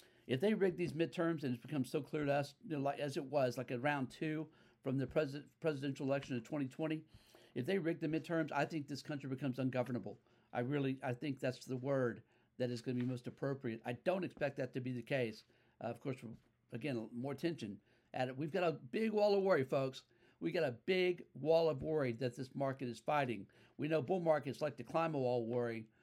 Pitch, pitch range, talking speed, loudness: 135 Hz, 125-155 Hz, 235 wpm, -39 LUFS